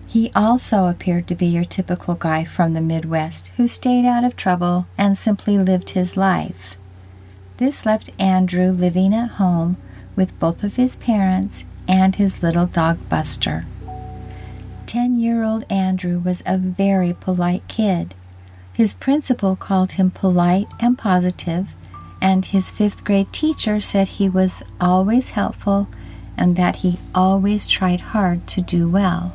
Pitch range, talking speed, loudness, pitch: 175-200 Hz, 145 wpm, -18 LUFS, 185 Hz